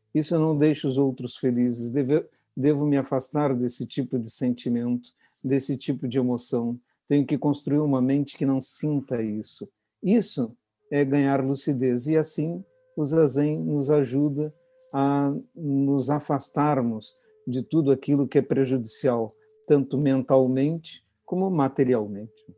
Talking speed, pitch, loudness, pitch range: 135 wpm, 140 Hz, -25 LUFS, 130-150 Hz